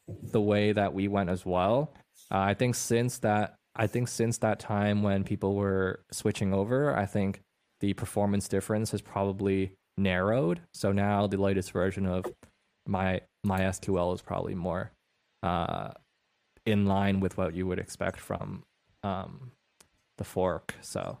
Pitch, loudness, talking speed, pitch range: 100 Hz, -30 LUFS, 155 wpm, 95-110 Hz